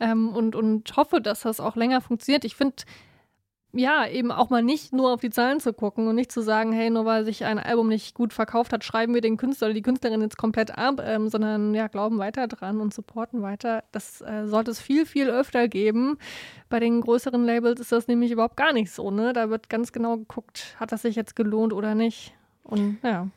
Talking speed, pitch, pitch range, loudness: 230 wpm, 230 Hz, 220-240 Hz, -25 LUFS